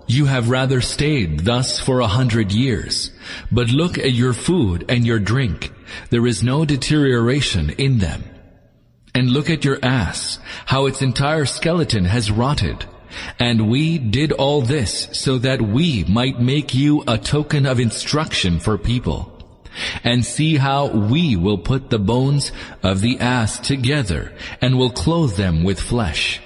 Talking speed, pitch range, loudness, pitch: 155 wpm, 105-135 Hz, -18 LUFS, 125 Hz